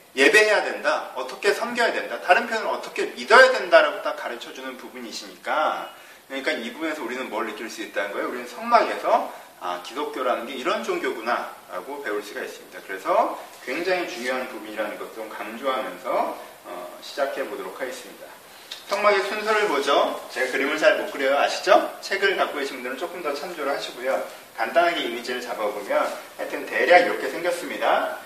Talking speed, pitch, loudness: 405 characters per minute, 215 Hz, -23 LUFS